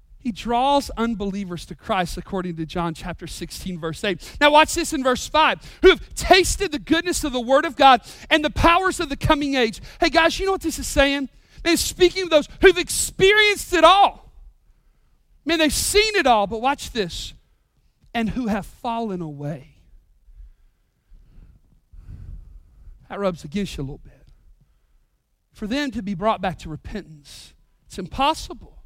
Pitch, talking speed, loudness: 240 Hz, 170 wpm, -20 LUFS